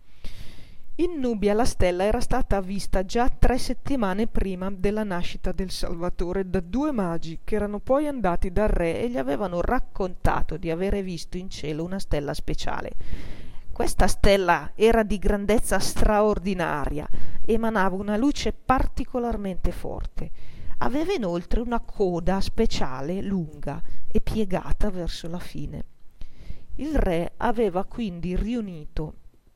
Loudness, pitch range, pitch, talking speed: -26 LUFS, 180-225 Hz, 200 Hz, 130 wpm